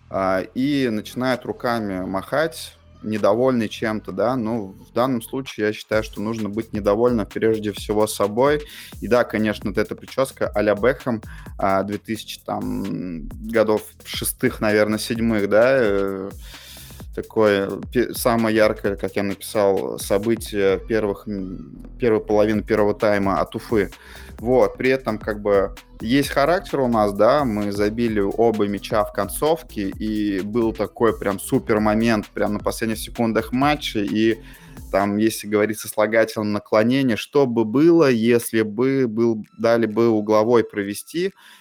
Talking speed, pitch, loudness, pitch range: 135 wpm, 110 Hz, -21 LUFS, 100-115 Hz